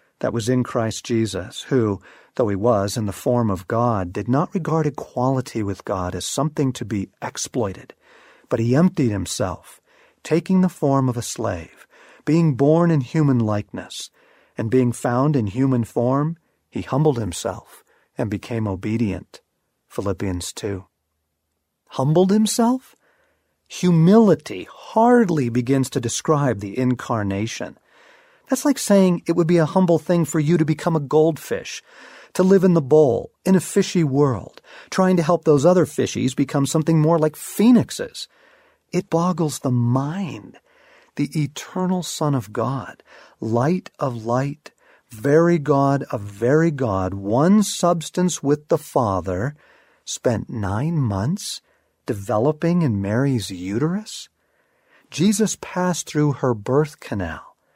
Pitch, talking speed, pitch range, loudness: 145 Hz, 140 wpm, 120-175 Hz, -20 LUFS